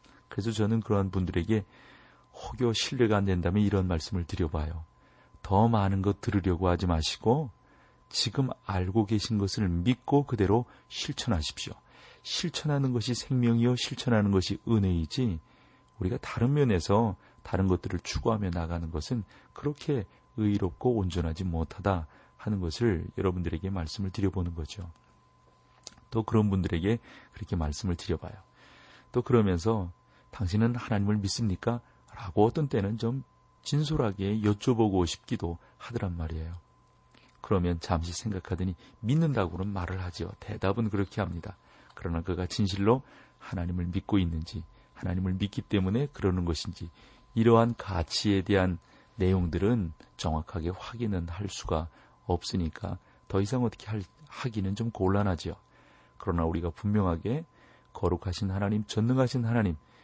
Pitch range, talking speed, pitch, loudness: 90-115 Hz, 320 characters per minute, 100 Hz, -30 LUFS